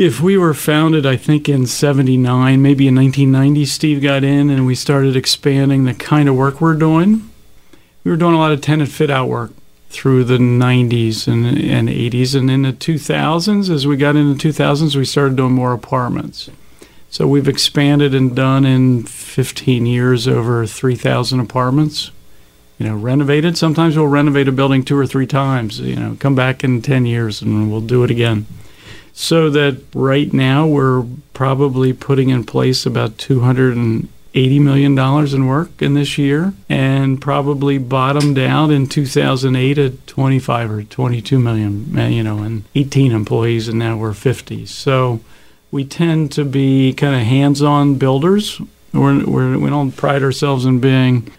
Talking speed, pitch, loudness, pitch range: 165 wpm, 135 Hz, -14 LUFS, 125-145 Hz